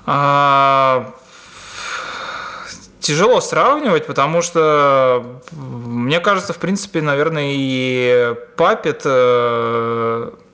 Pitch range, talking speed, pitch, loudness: 125-165 Hz, 70 wpm, 135 Hz, -15 LUFS